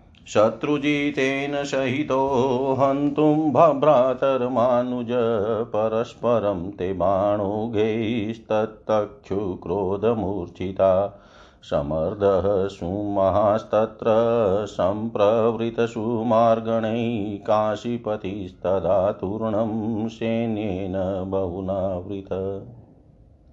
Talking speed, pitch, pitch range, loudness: 35 wpm, 110 Hz, 100-120 Hz, -23 LUFS